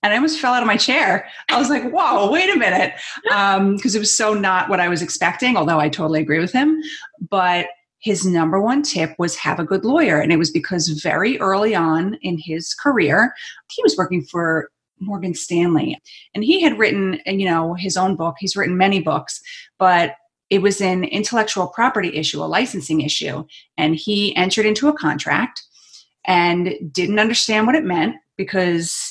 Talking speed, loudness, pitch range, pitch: 190 wpm, -18 LUFS, 170-215 Hz, 185 Hz